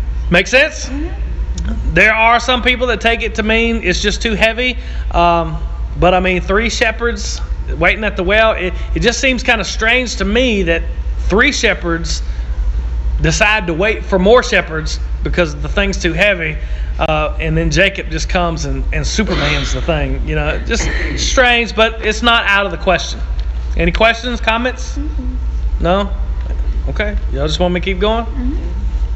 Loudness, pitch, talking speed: -14 LUFS, 180 Hz, 170 wpm